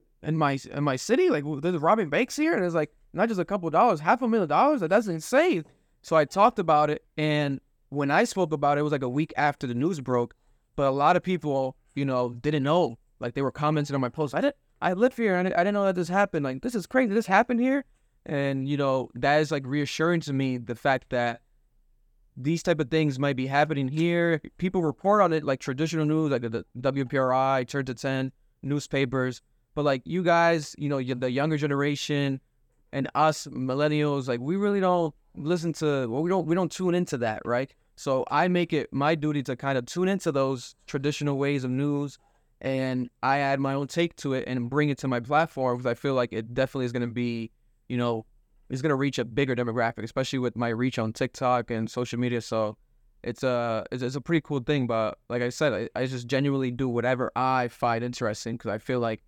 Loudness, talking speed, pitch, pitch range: -26 LUFS, 230 wpm, 140 Hz, 125-160 Hz